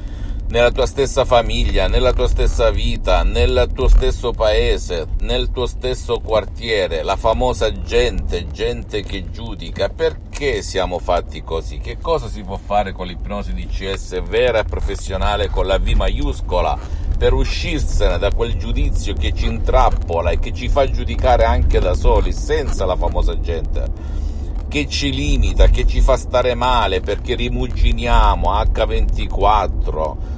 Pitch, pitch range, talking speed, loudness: 90 Hz, 80-120 Hz, 145 wpm, -19 LUFS